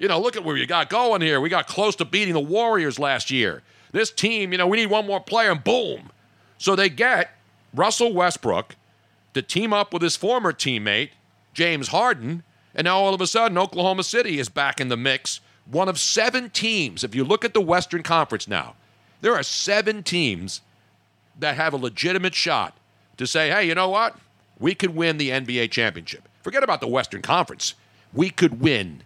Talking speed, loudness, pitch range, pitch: 200 wpm, -22 LUFS, 120-195 Hz, 170 Hz